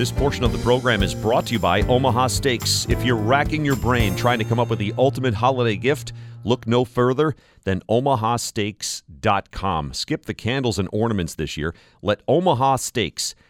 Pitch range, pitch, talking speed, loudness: 110-130 Hz, 120 Hz, 180 wpm, -21 LUFS